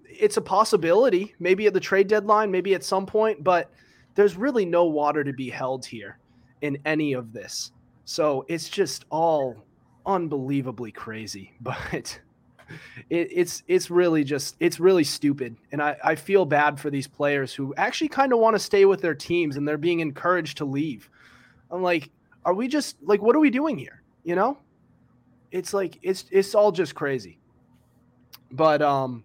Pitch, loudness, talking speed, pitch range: 165 Hz, -24 LUFS, 175 wpm, 140-195 Hz